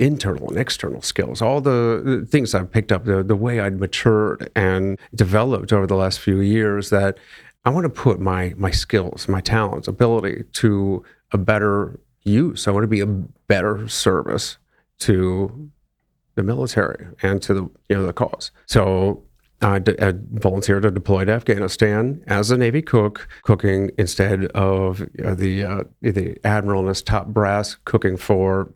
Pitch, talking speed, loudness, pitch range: 100 Hz, 165 wpm, -20 LUFS, 95-110 Hz